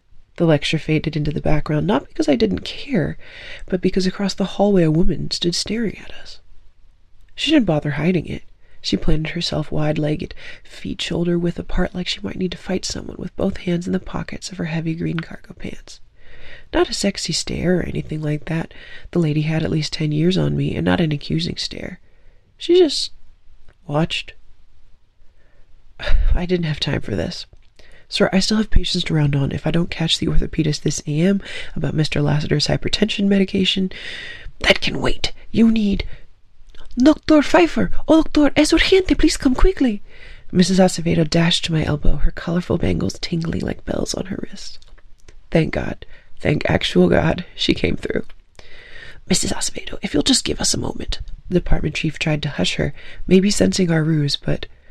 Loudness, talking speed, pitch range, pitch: -19 LUFS, 180 wpm, 150-200 Hz, 175 Hz